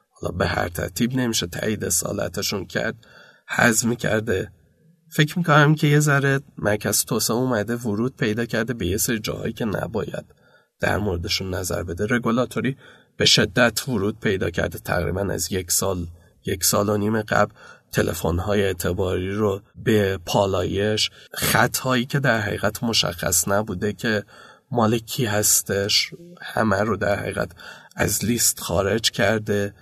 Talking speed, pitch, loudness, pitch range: 135 wpm, 105 Hz, -22 LUFS, 95-120 Hz